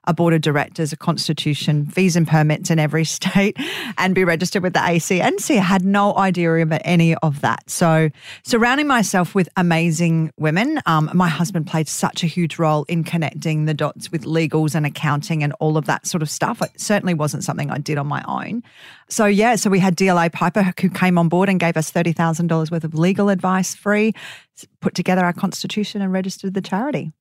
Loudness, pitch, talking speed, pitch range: -18 LUFS, 170 Hz, 205 wpm, 160-190 Hz